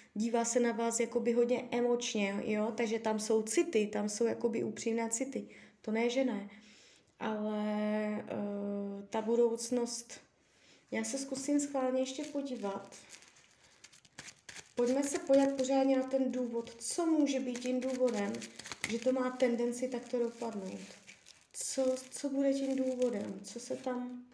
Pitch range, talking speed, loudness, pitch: 220-260 Hz, 140 wpm, -34 LUFS, 240 Hz